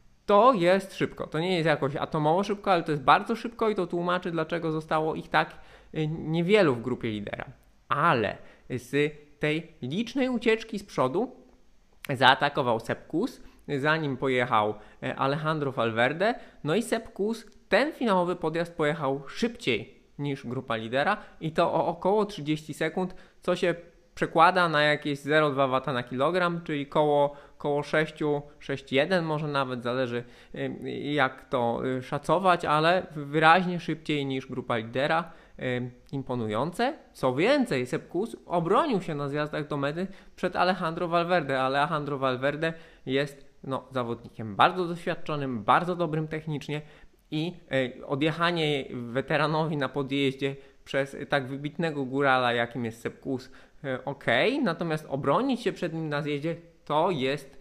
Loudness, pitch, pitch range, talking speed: -27 LUFS, 150 Hz, 135-175 Hz, 130 wpm